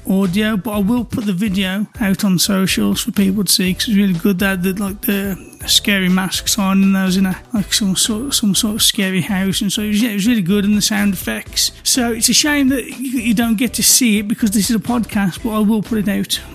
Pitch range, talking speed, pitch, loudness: 195-225 Hz, 270 wpm, 205 Hz, -15 LUFS